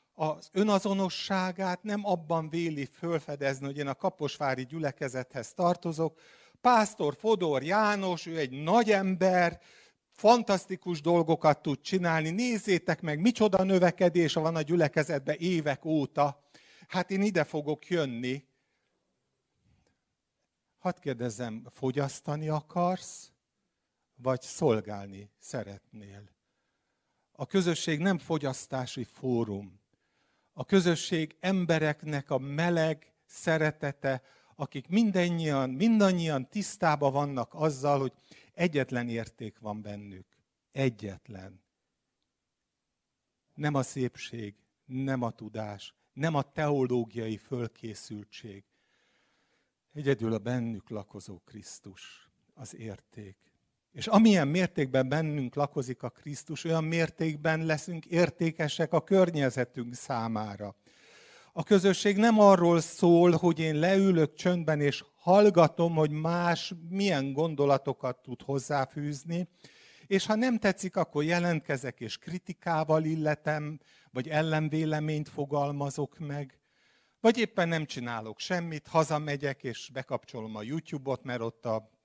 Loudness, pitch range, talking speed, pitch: -29 LUFS, 130-175 Hz, 105 wpm, 150 Hz